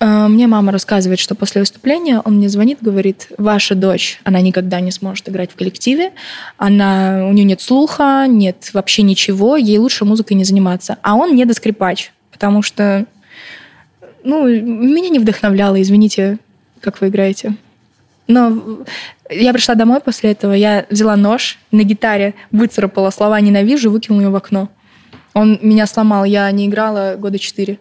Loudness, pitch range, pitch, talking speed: -13 LUFS, 195-225 Hz, 210 Hz, 150 wpm